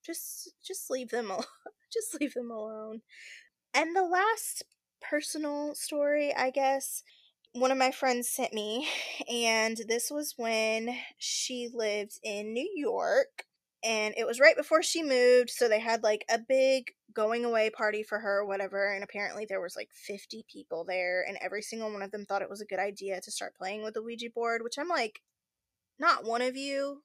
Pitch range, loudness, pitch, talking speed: 215-290 Hz, -30 LUFS, 235 Hz, 190 wpm